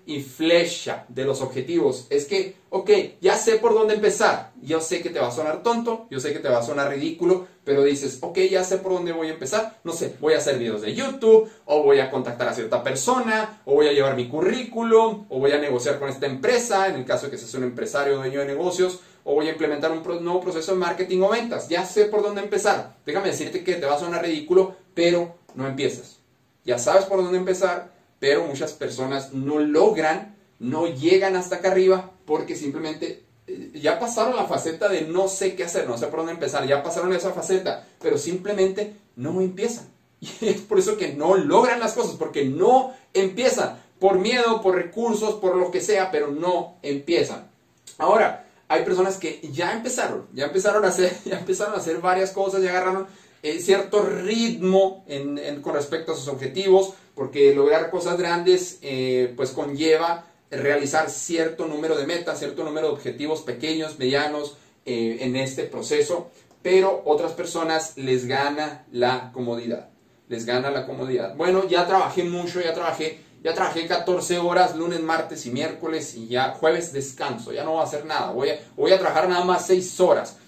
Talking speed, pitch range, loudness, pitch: 195 wpm, 150-195 Hz, -23 LUFS, 175 Hz